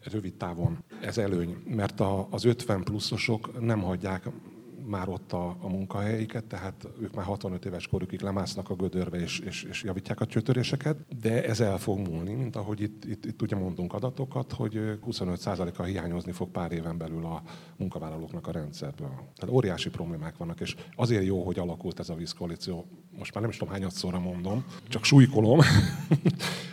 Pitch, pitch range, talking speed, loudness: 105 Hz, 90-120 Hz, 170 wpm, -30 LUFS